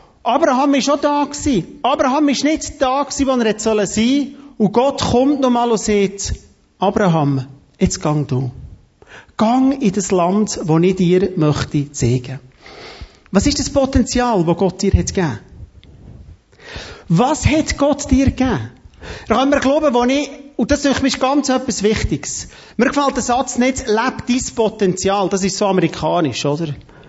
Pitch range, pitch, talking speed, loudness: 180-270 Hz, 225 Hz, 165 wpm, -16 LUFS